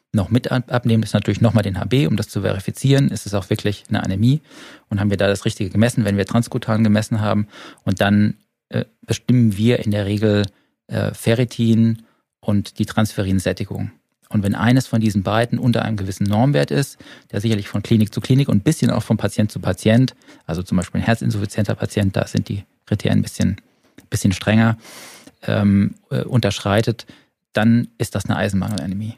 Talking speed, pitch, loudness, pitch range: 185 wpm, 110 Hz, -19 LUFS, 100-115 Hz